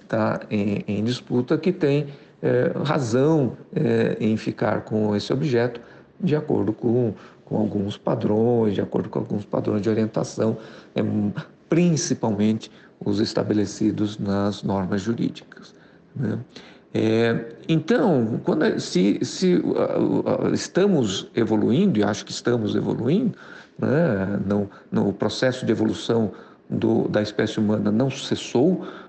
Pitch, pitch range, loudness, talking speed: 110 Hz, 105-130 Hz, -23 LUFS, 130 wpm